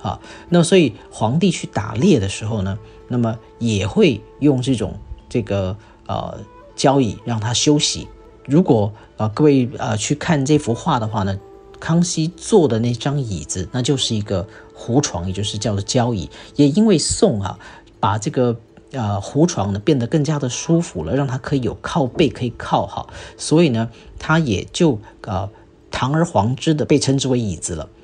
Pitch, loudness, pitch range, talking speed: 120 Hz, -19 LUFS, 110-150 Hz, 250 characters per minute